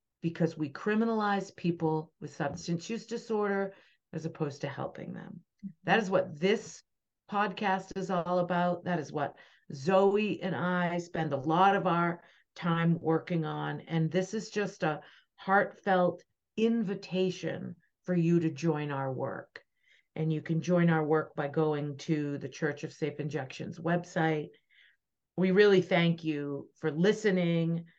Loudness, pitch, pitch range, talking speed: -31 LUFS, 170 Hz, 160-190 Hz, 150 wpm